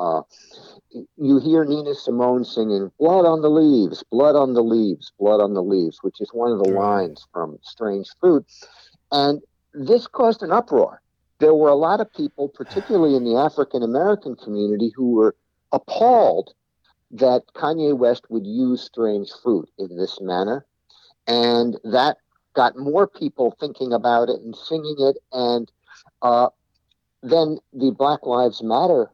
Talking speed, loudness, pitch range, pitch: 155 wpm, -20 LUFS, 115-155 Hz, 130 Hz